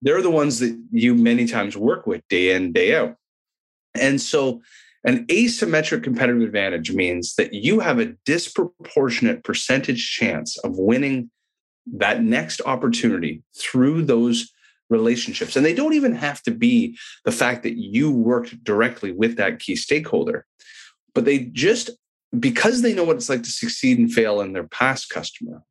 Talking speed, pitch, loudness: 160 wpm, 145 Hz, -20 LUFS